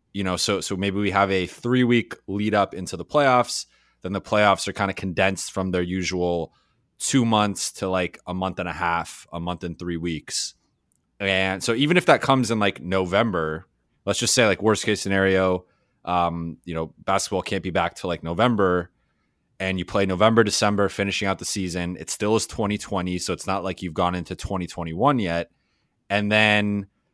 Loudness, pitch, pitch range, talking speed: -23 LUFS, 95 Hz, 90-100 Hz, 195 wpm